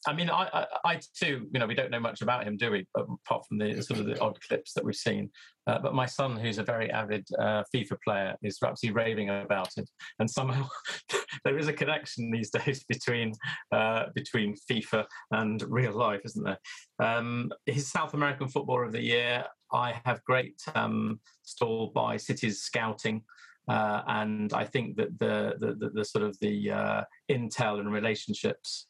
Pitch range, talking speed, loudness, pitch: 110-135 Hz, 190 wpm, -31 LUFS, 120 Hz